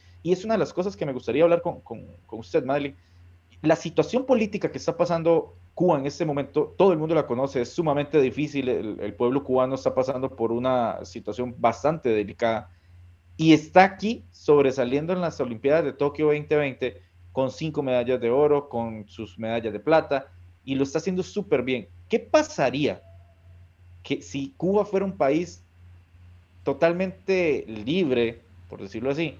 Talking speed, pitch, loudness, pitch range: 170 wpm, 135 Hz, -24 LUFS, 105-160 Hz